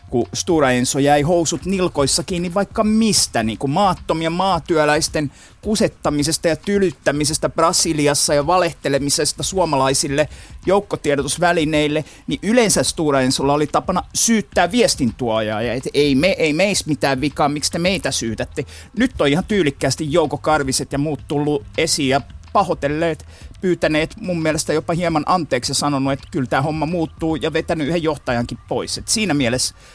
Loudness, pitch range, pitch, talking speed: -18 LUFS, 140-175 Hz, 155 Hz, 140 wpm